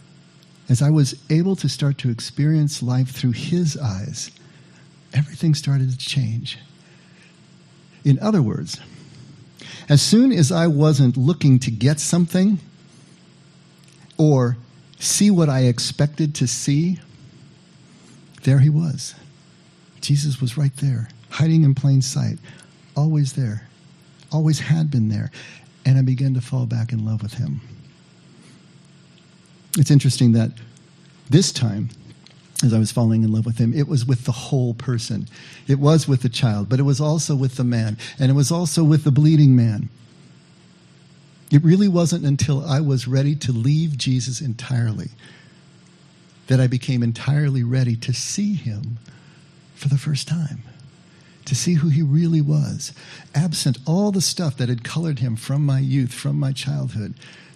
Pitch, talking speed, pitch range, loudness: 145 Hz, 150 wpm, 130-160 Hz, -19 LUFS